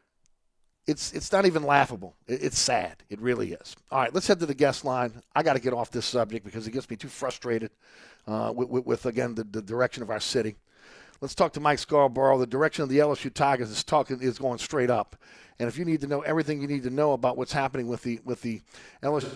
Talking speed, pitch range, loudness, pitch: 240 wpm, 120-145 Hz, -27 LUFS, 130 Hz